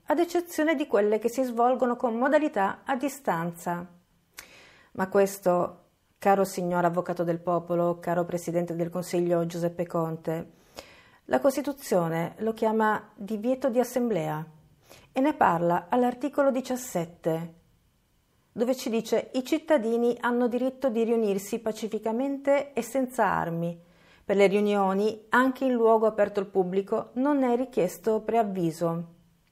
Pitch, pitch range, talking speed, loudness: 215 Hz, 175-250 Hz, 125 wpm, -27 LUFS